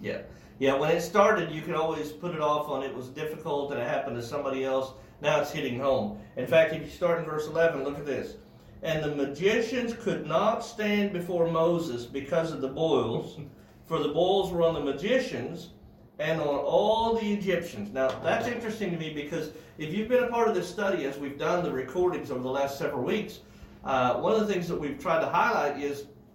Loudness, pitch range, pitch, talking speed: -28 LUFS, 140-180 Hz, 160 Hz, 215 wpm